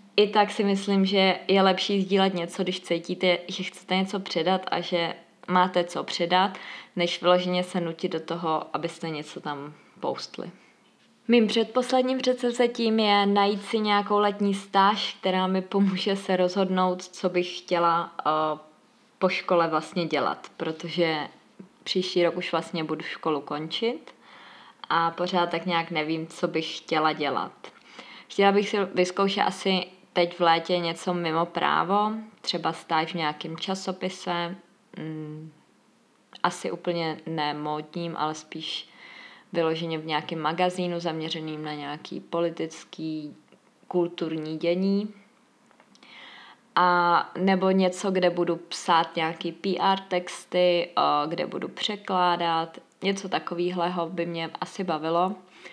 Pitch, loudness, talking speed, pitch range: 180 Hz, -26 LUFS, 130 wpm, 165-195 Hz